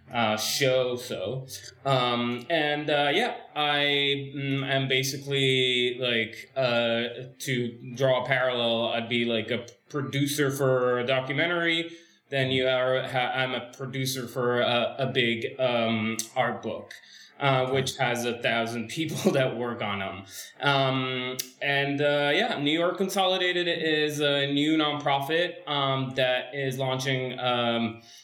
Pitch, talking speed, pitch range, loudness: 130 Hz, 135 wpm, 120-140 Hz, -26 LUFS